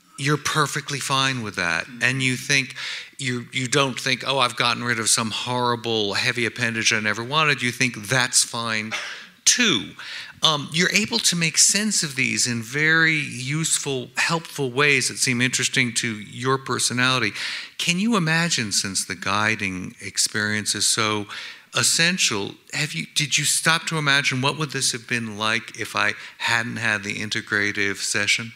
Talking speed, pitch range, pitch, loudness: 165 wpm, 110-145 Hz, 125 Hz, -21 LUFS